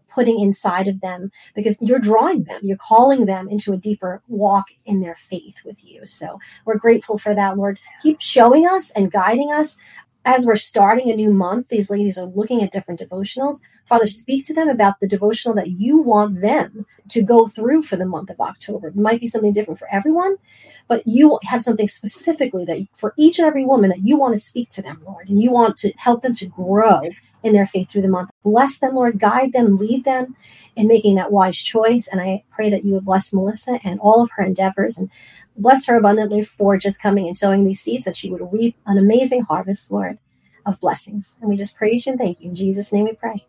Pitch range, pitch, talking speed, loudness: 195-235 Hz, 210 Hz, 225 wpm, -17 LUFS